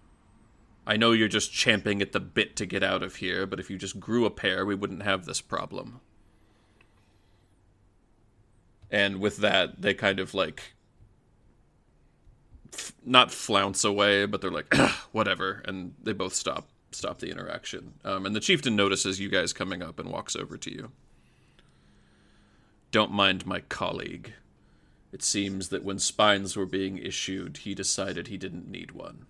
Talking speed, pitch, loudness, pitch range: 160 wpm, 100 Hz, -27 LUFS, 95-105 Hz